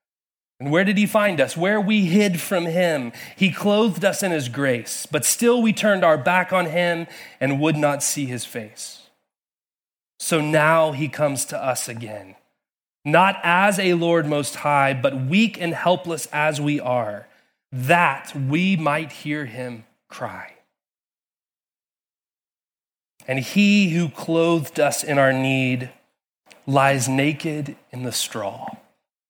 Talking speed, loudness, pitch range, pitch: 145 wpm, -20 LUFS, 135-180 Hz, 155 Hz